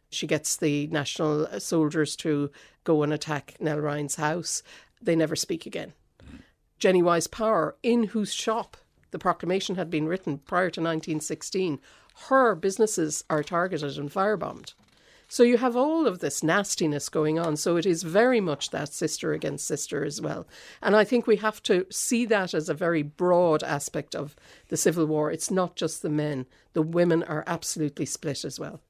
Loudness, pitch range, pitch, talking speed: -26 LUFS, 150-195 Hz, 165 Hz, 175 wpm